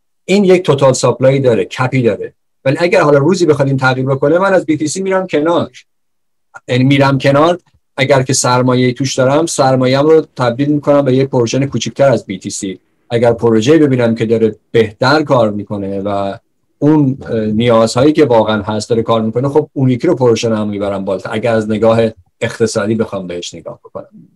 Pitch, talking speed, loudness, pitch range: 130 Hz, 170 wpm, -12 LUFS, 115-145 Hz